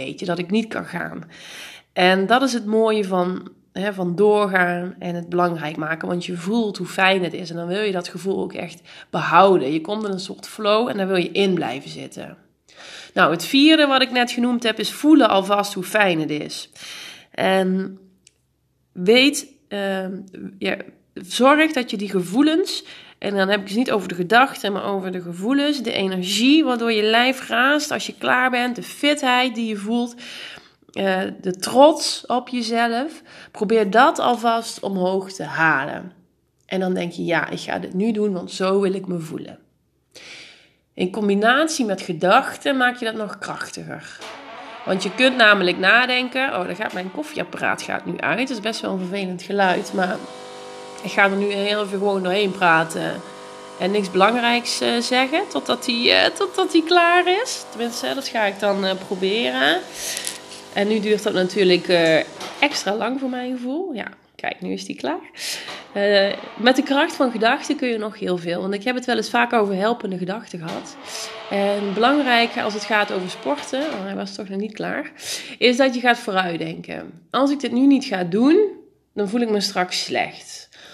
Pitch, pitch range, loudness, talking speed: 210 Hz, 190-250 Hz, -20 LUFS, 185 wpm